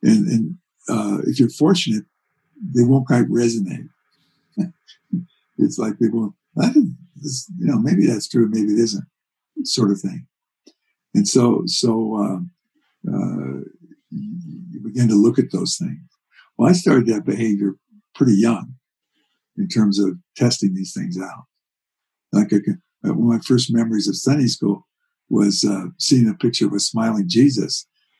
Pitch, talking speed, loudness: 120 Hz, 145 wpm, -19 LUFS